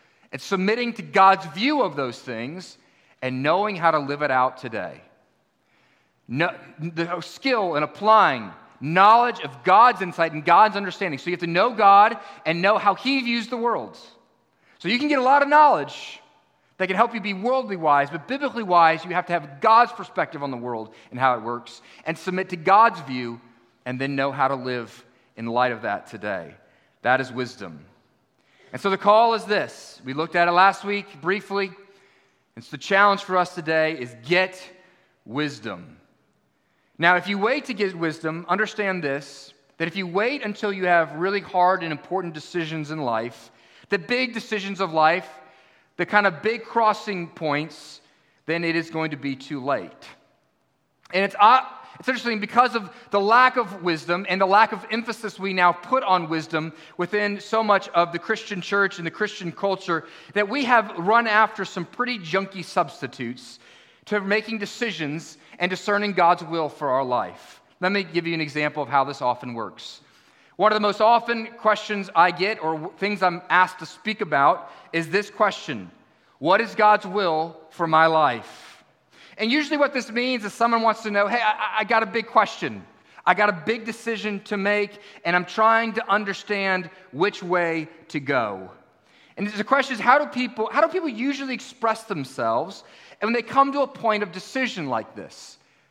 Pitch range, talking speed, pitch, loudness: 160-215 Hz, 185 wpm, 190 Hz, -22 LUFS